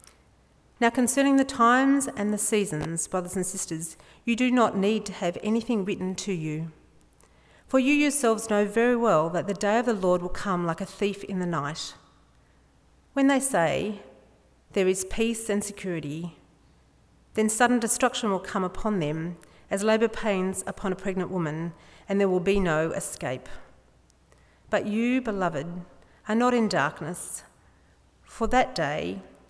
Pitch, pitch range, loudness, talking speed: 200 Hz, 175-230 Hz, -26 LUFS, 160 wpm